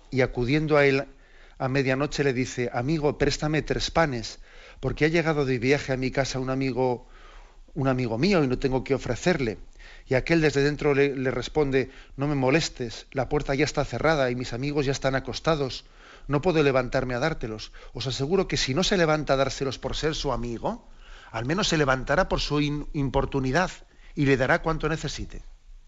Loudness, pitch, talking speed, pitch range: -25 LUFS, 135 Hz, 190 wpm, 130-150 Hz